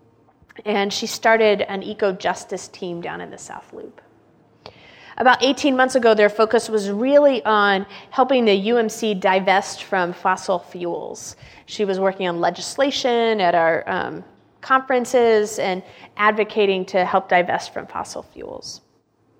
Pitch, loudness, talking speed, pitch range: 205 Hz, -19 LUFS, 140 wpm, 190-235 Hz